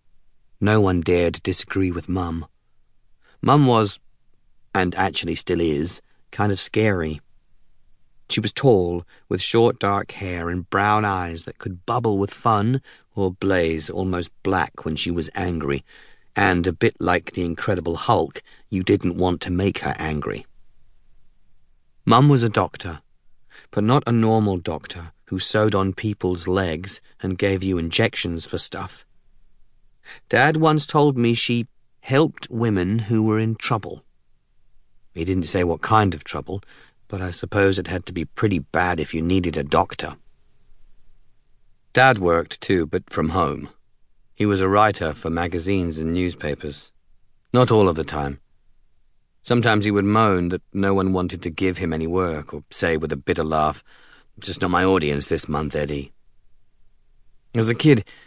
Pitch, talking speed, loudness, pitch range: 95 Hz, 155 wpm, -21 LUFS, 85-110 Hz